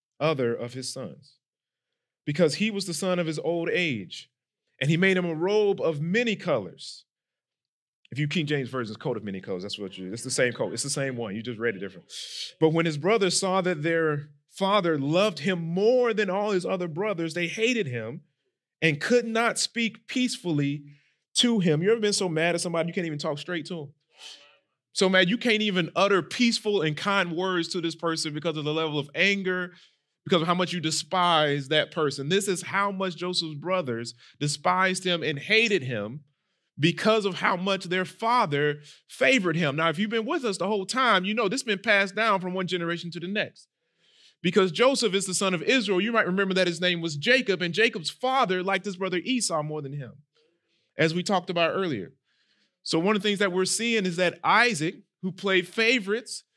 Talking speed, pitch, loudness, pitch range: 210 wpm, 180 Hz, -25 LUFS, 155-200 Hz